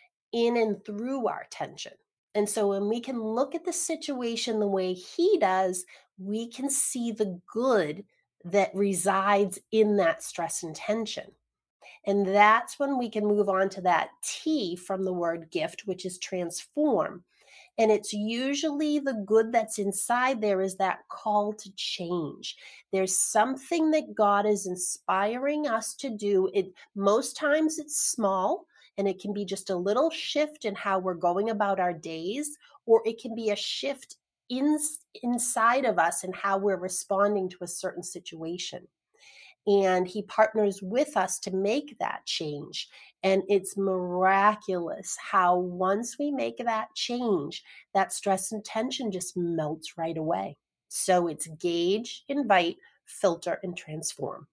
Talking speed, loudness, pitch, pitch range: 155 wpm, -28 LUFS, 205 Hz, 185-240 Hz